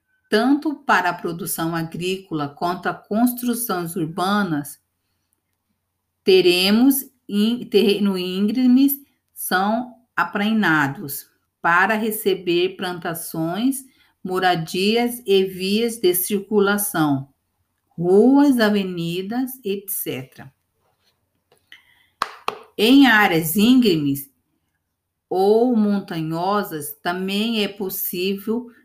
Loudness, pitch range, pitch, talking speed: -20 LUFS, 160-220 Hz, 190 Hz, 70 wpm